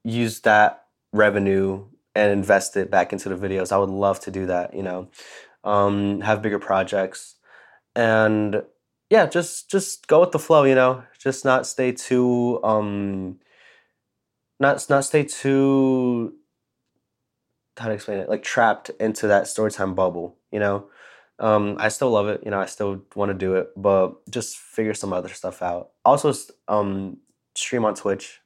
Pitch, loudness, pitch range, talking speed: 105 Hz, -21 LUFS, 100-125 Hz, 165 wpm